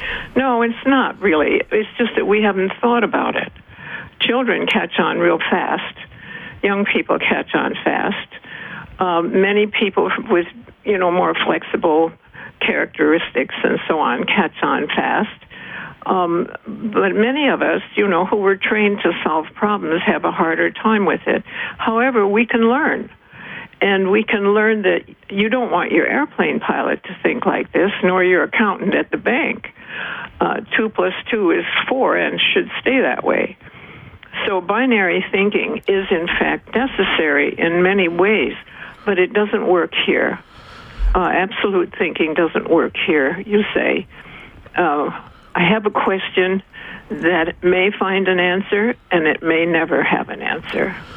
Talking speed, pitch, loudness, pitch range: 155 wpm, 200 Hz, -17 LUFS, 180-220 Hz